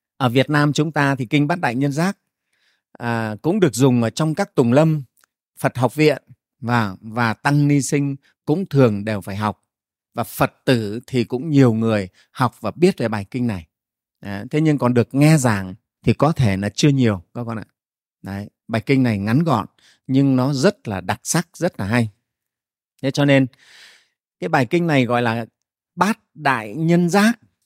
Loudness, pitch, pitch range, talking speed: -19 LUFS, 130 Hz, 115-150 Hz, 195 wpm